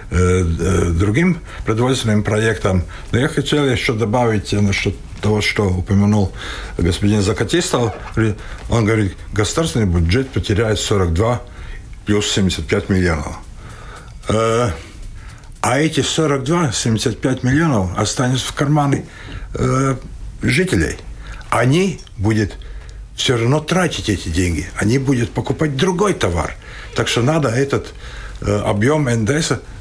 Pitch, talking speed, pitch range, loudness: 110 Hz, 100 wpm, 100-135 Hz, -17 LUFS